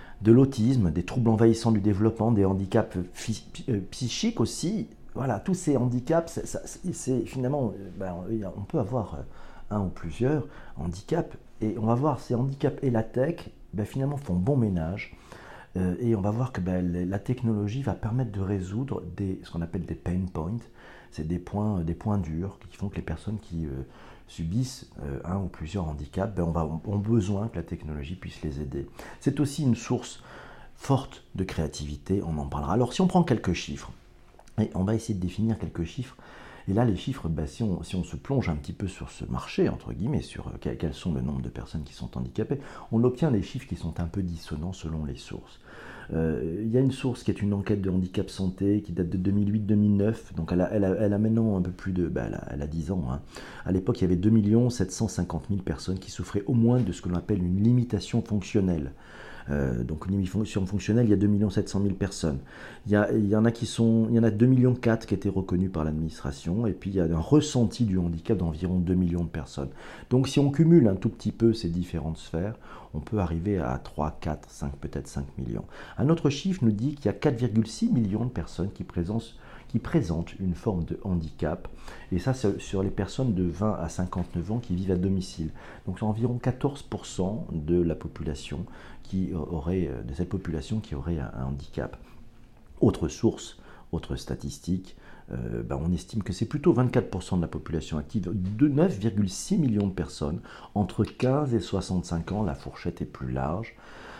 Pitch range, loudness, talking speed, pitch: 85-115 Hz, -28 LUFS, 210 wpm, 95 Hz